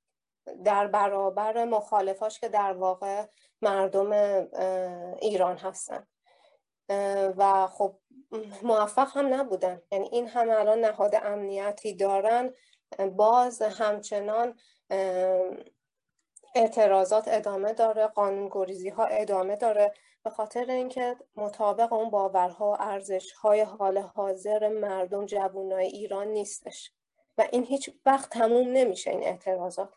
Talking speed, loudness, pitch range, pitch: 105 wpm, -27 LUFS, 195-225 Hz, 205 Hz